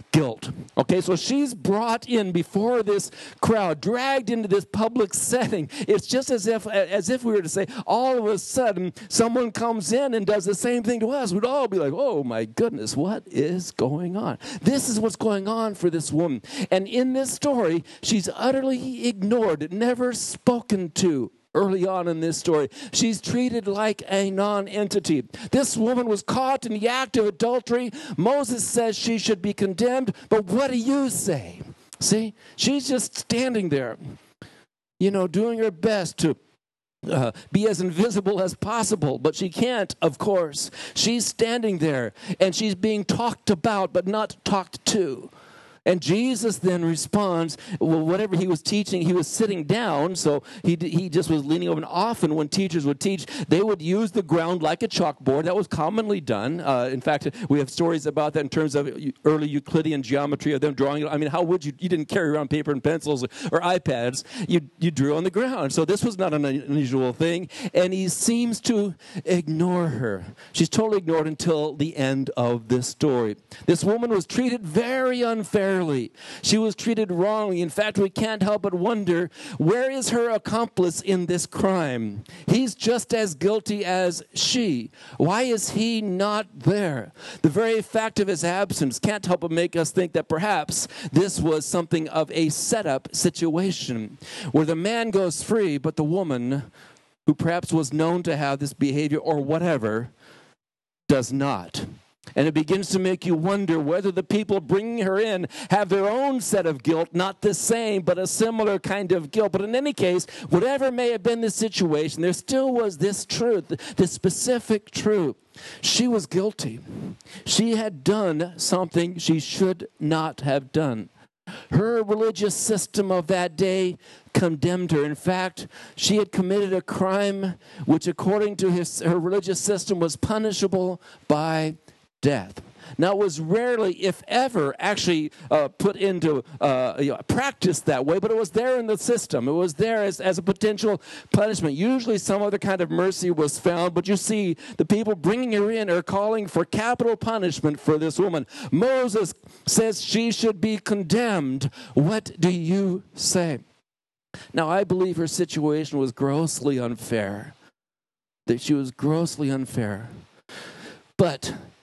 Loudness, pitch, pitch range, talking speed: -24 LUFS, 190 Hz, 160-220 Hz, 175 wpm